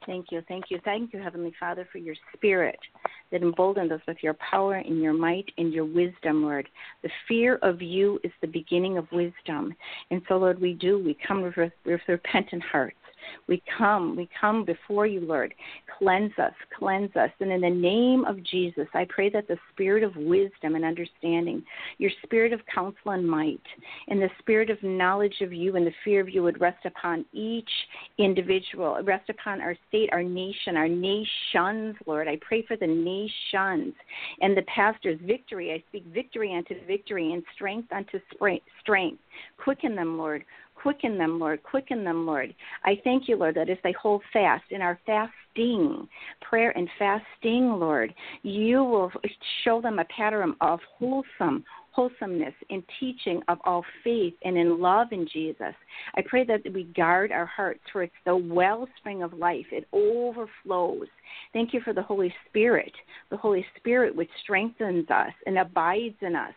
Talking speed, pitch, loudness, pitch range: 180 wpm, 190 Hz, -27 LUFS, 175-220 Hz